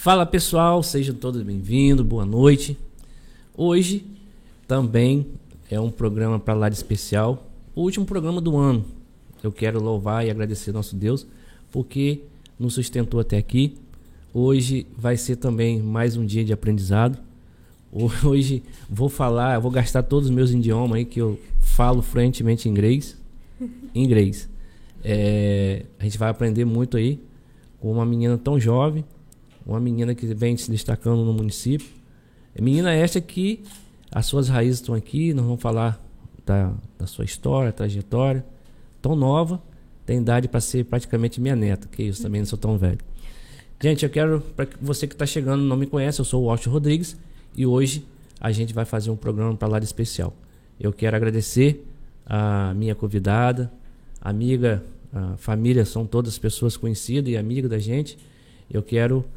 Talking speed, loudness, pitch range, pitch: 160 wpm, -22 LUFS, 110-135 Hz, 120 Hz